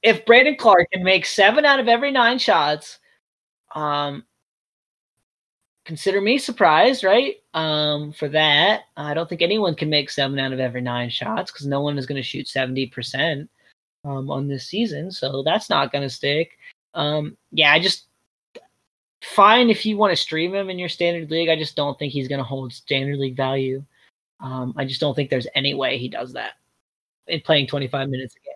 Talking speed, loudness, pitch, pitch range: 195 wpm, -20 LUFS, 150 Hz, 135-185 Hz